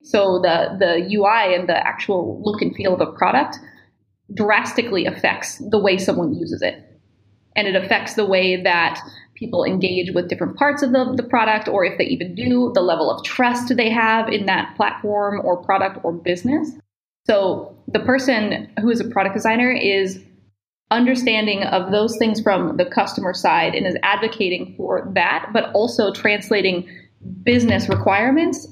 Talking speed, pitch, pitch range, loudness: 165 wpm, 210 Hz, 190-240 Hz, -19 LUFS